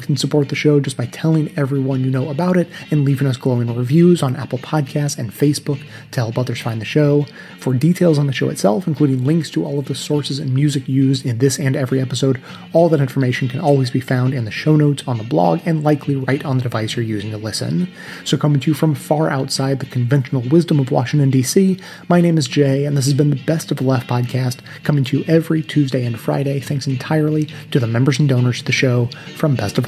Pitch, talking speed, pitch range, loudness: 140 Hz, 240 wpm, 130-150 Hz, -17 LUFS